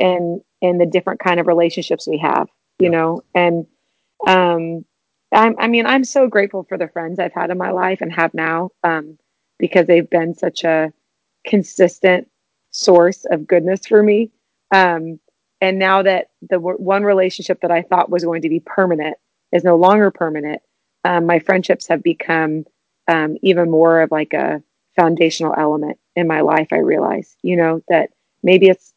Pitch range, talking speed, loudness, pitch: 165-190 Hz, 175 wpm, -16 LUFS, 175 Hz